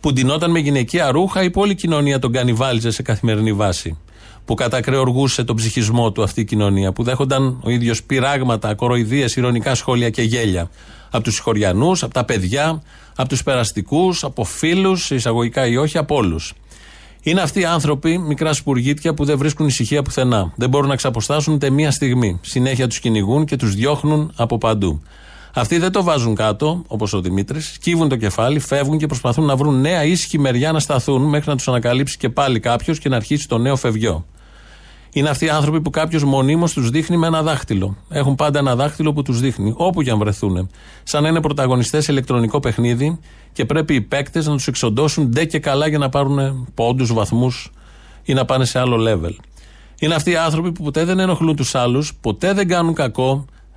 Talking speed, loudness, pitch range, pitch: 190 wpm, -17 LUFS, 115-150 Hz, 135 Hz